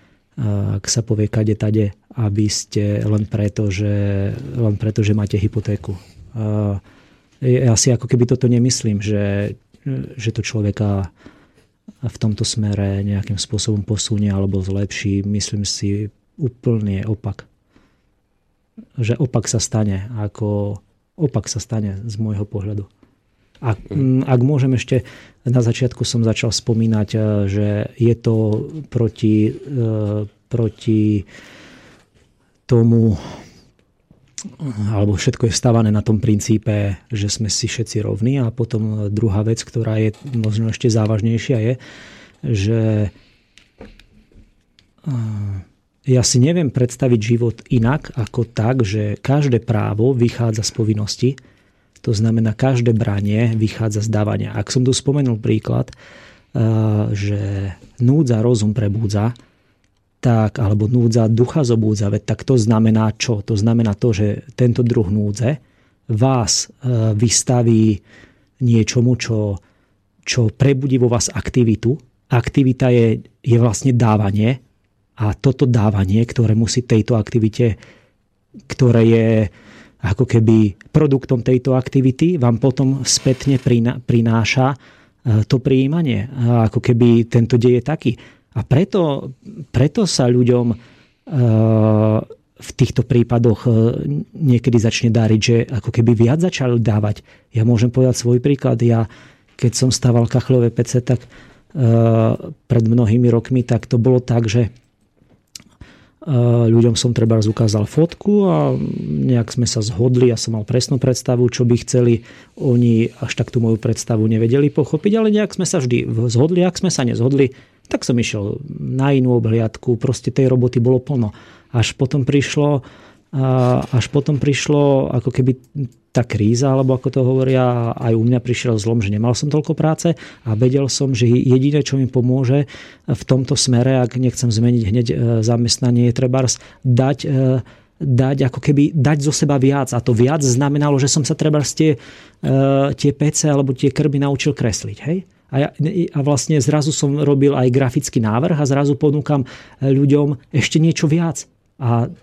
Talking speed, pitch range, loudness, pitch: 135 wpm, 110-130 Hz, -17 LUFS, 120 Hz